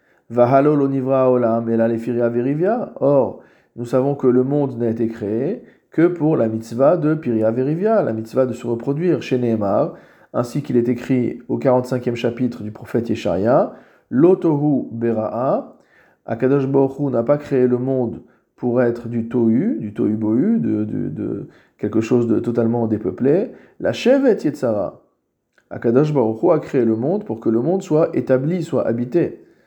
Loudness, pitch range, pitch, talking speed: -19 LUFS, 115-135 Hz, 120 Hz, 150 wpm